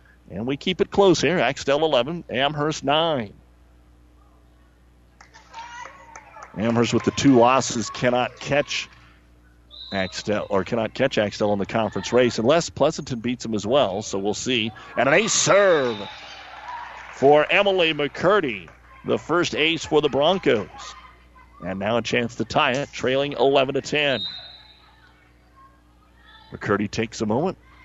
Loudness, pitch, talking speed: -21 LUFS, 115 Hz, 135 wpm